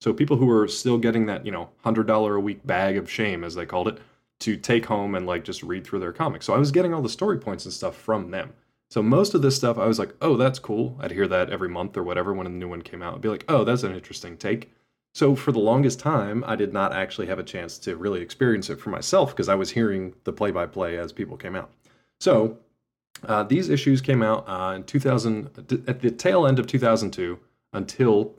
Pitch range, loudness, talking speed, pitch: 100-130 Hz, -24 LUFS, 250 wpm, 110 Hz